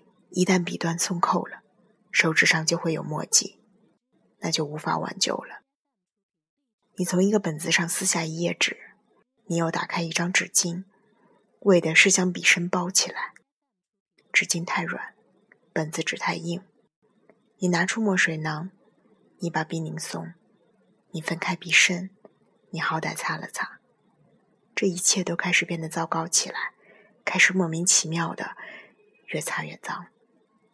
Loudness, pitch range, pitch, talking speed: -24 LUFS, 165-200 Hz, 180 Hz, 205 characters per minute